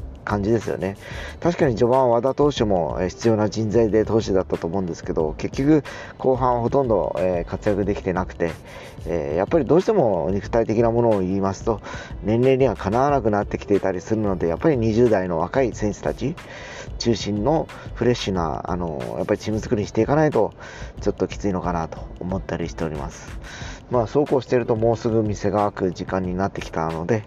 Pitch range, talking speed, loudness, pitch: 95-120 Hz, 380 characters per minute, -22 LUFS, 110 Hz